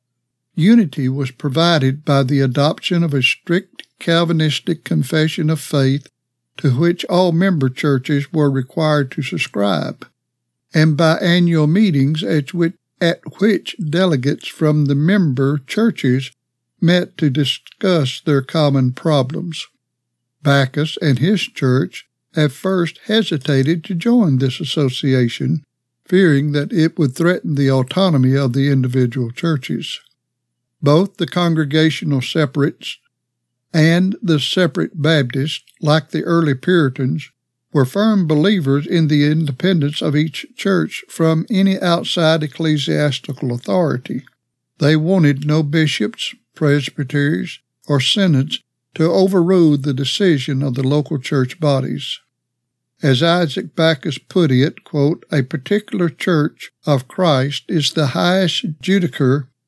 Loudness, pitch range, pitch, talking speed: -17 LUFS, 135-170 Hz, 150 Hz, 120 wpm